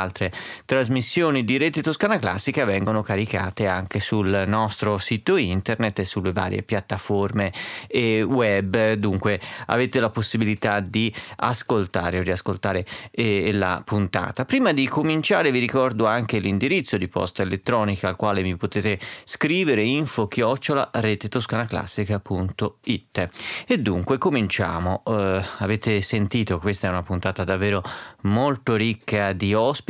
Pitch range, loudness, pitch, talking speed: 100-115 Hz, -23 LUFS, 105 Hz, 125 wpm